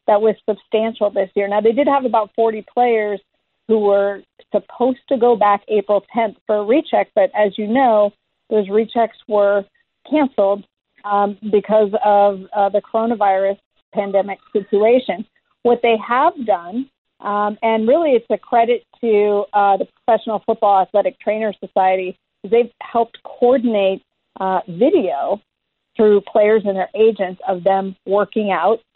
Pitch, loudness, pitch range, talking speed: 215 Hz, -17 LUFS, 200-235 Hz, 150 wpm